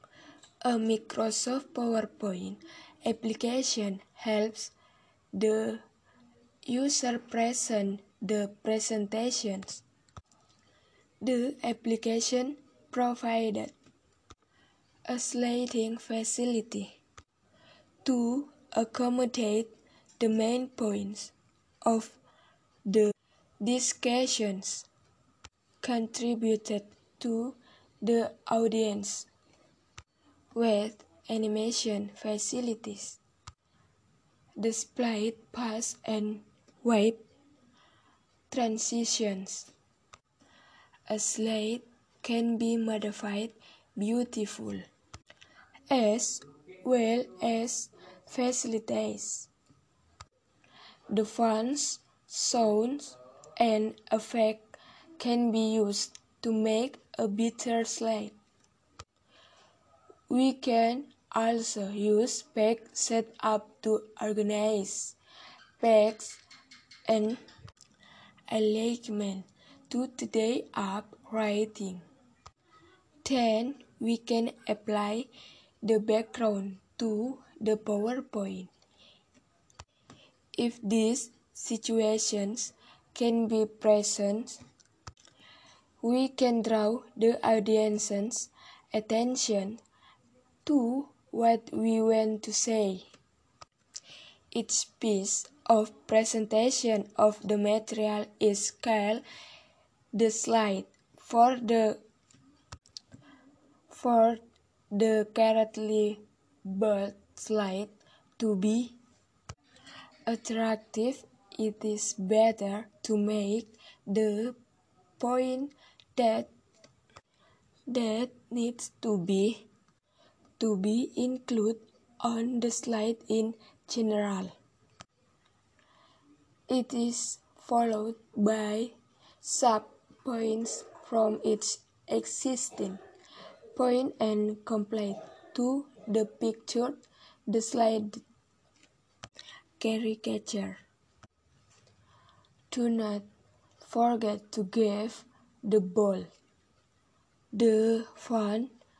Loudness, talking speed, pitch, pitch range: -30 LUFS, 70 wpm, 225 Hz, 215-240 Hz